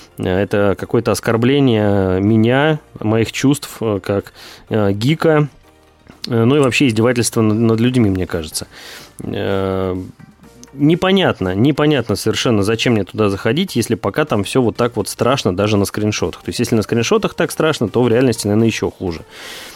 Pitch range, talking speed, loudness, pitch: 100-130 Hz, 145 wpm, -16 LUFS, 115 Hz